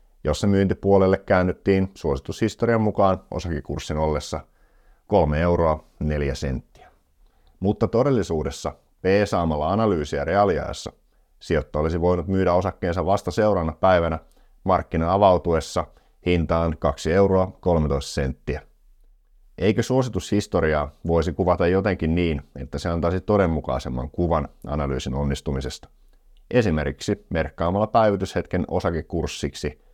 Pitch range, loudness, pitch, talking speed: 75-95 Hz, -23 LUFS, 85 Hz, 95 wpm